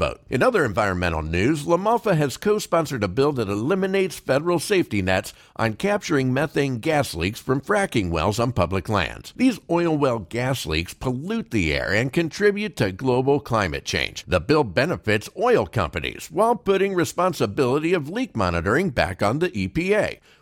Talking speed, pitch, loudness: 160 wpm, 135 Hz, -22 LUFS